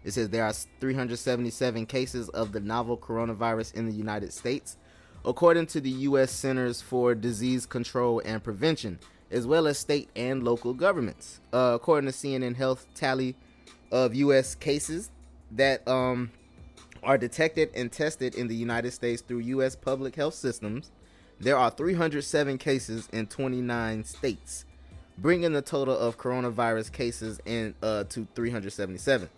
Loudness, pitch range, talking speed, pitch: -28 LUFS, 110-135 Hz, 145 wpm, 120 Hz